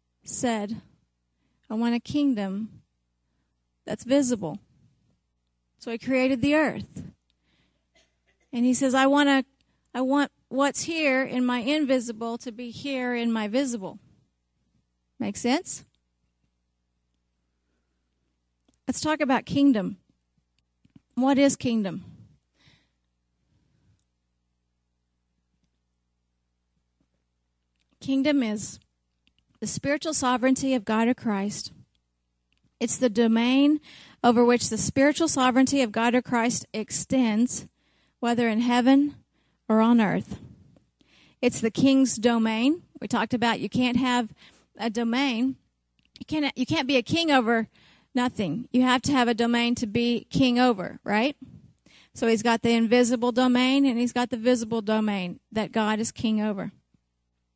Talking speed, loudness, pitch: 120 wpm, -24 LUFS, 235 Hz